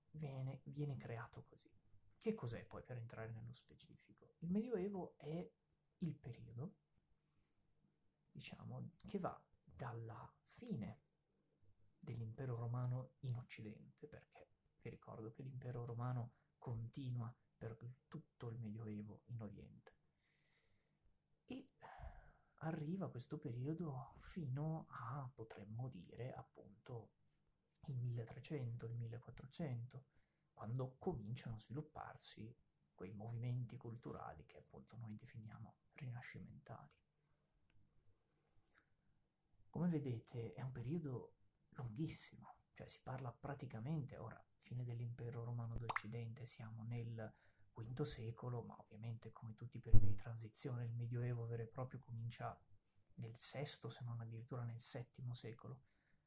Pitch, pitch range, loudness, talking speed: 120 Hz, 115-135 Hz, -50 LUFS, 110 wpm